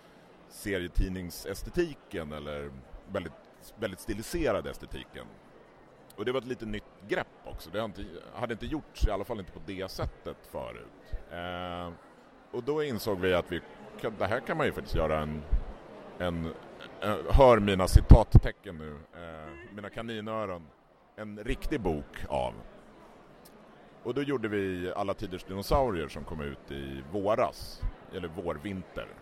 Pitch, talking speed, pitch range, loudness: 90 Hz, 145 wpm, 80-105 Hz, -31 LUFS